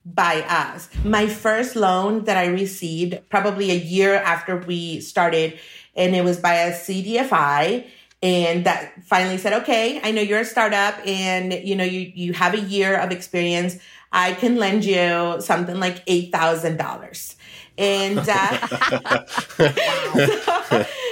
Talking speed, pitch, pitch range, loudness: 140 wpm, 185 Hz, 175-205 Hz, -20 LUFS